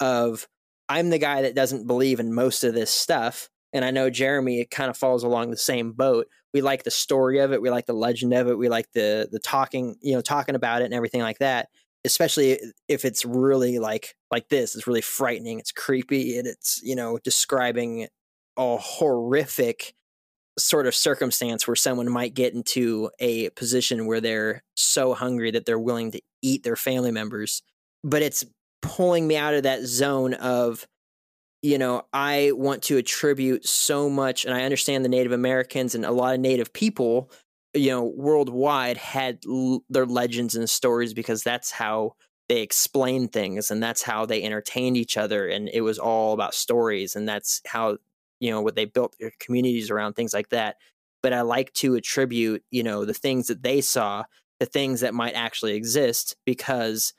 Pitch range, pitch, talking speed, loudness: 115-135 Hz, 125 Hz, 190 wpm, -24 LUFS